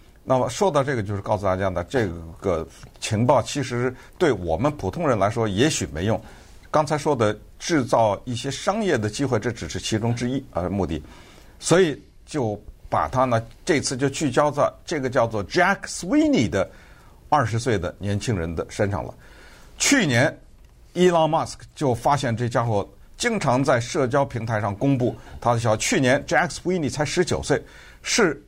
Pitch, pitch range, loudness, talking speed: 120 Hz, 100-140 Hz, -23 LUFS, 295 characters per minute